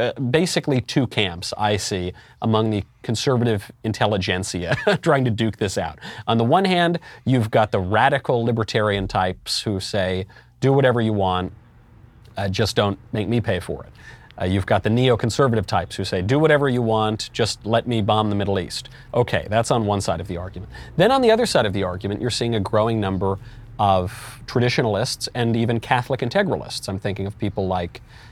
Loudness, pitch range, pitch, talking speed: -21 LUFS, 100-125 Hz, 110 Hz, 190 wpm